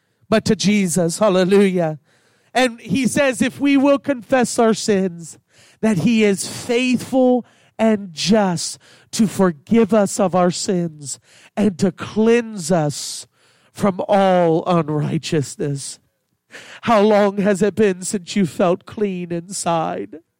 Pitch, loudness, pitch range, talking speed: 200 Hz, -18 LUFS, 170-220 Hz, 125 wpm